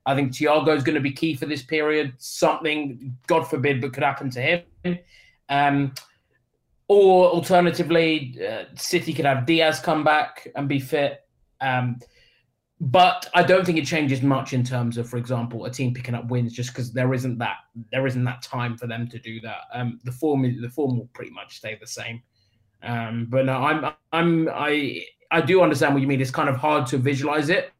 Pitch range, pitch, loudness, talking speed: 125-160 Hz, 140 Hz, -22 LUFS, 205 wpm